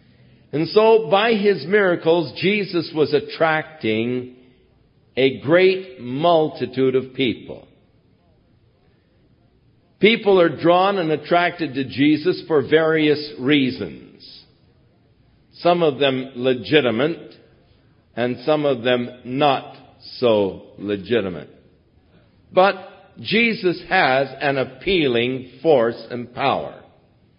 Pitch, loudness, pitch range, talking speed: 150 Hz, -19 LUFS, 125-185 Hz, 90 wpm